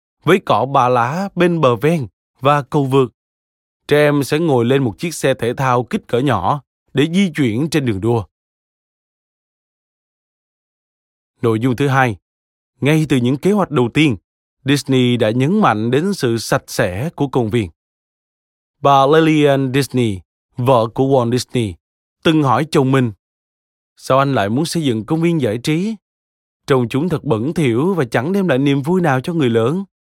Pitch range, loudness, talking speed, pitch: 115-155 Hz, -16 LUFS, 175 wpm, 135 Hz